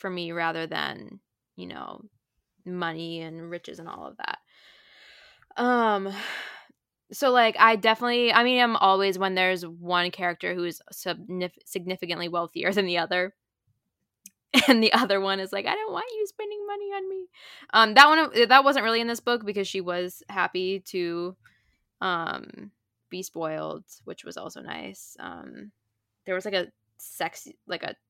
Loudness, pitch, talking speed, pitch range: -24 LUFS, 190 Hz, 165 wpm, 175-235 Hz